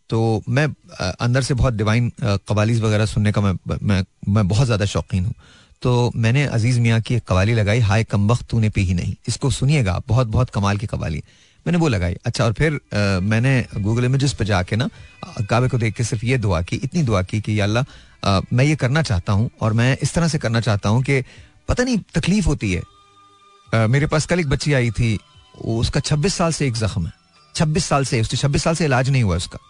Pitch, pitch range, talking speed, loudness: 120 Hz, 105-140 Hz, 220 wpm, -20 LUFS